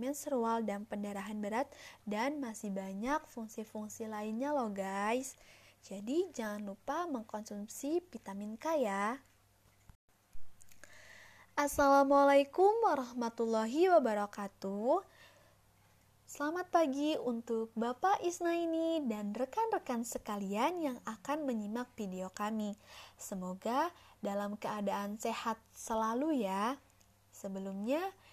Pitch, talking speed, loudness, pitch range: 230 Hz, 90 wpm, -35 LUFS, 205-285 Hz